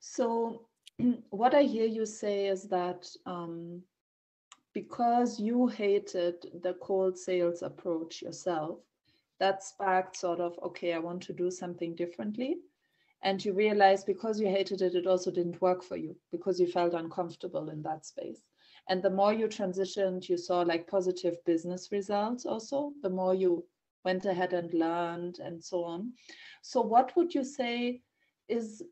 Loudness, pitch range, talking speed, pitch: -32 LUFS, 175-220 Hz, 160 wpm, 190 Hz